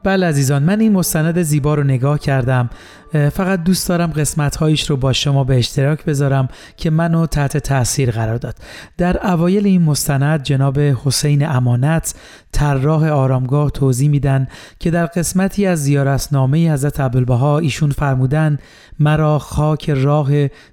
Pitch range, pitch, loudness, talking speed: 135-160 Hz, 145 Hz, -16 LUFS, 140 wpm